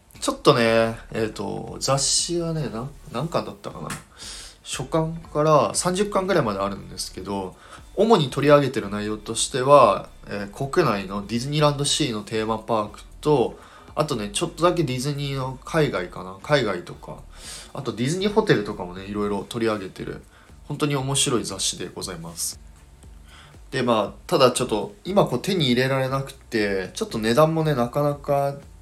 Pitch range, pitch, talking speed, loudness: 100-145 Hz, 120 Hz, 350 characters per minute, -23 LUFS